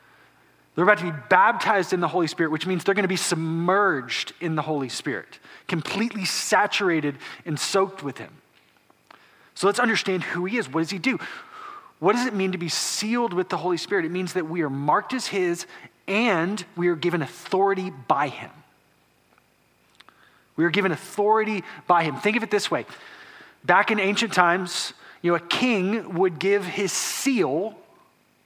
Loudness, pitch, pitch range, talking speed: -23 LUFS, 185 Hz, 170-205 Hz, 175 wpm